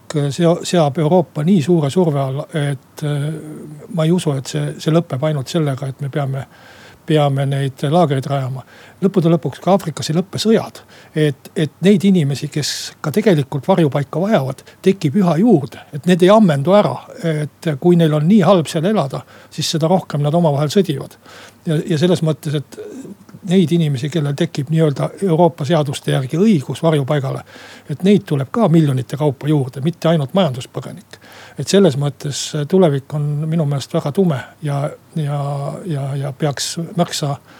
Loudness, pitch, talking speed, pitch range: -17 LUFS, 155 Hz, 165 wpm, 145-175 Hz